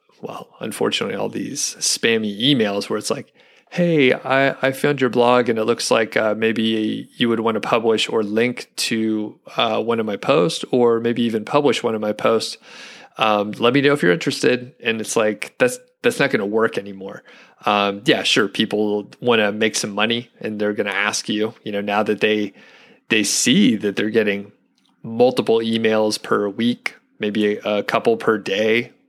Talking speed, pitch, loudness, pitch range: 195 wpm, 115 Hz, -19 LUFS, 105-130 Hz